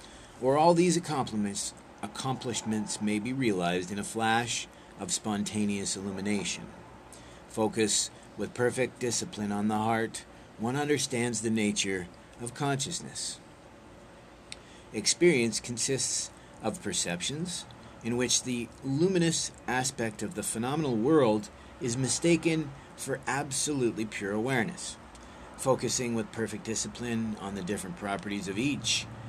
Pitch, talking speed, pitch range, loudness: 115 Hz, 115 wpm, 105-130 Hz, -30 LUFS